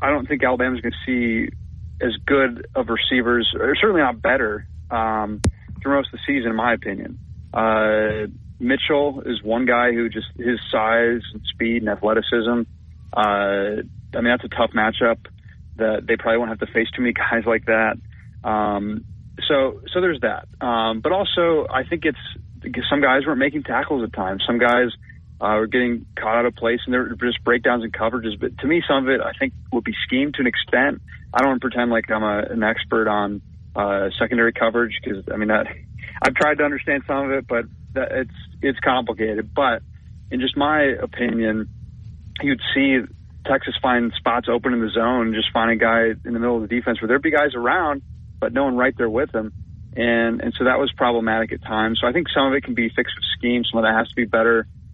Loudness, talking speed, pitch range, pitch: -20 LUFS, 215 wpm, 110-125 Hz, 115 Hz